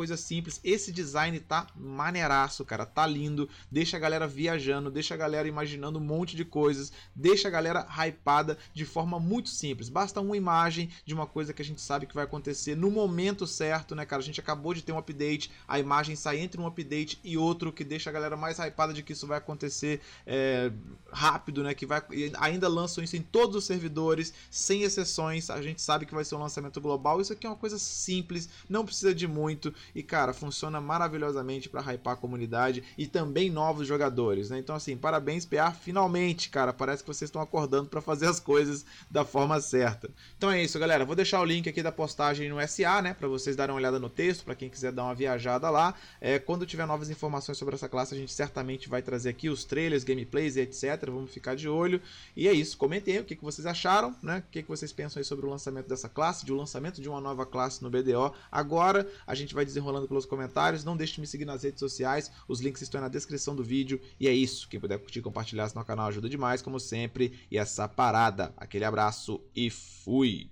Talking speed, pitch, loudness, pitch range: 225 wpm, 150 Hz, -31 LUFS, 135-165 Hz